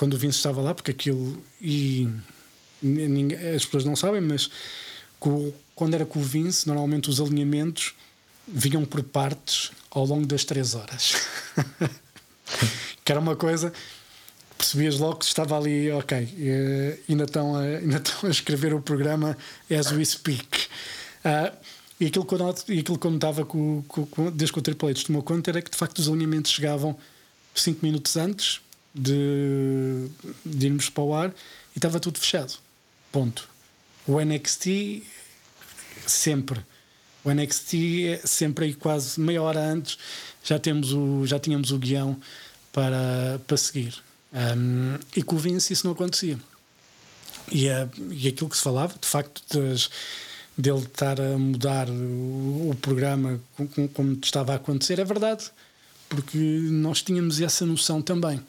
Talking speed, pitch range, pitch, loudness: 150 wpm, 135-160 Hz, 145 Hz, -25 LUFS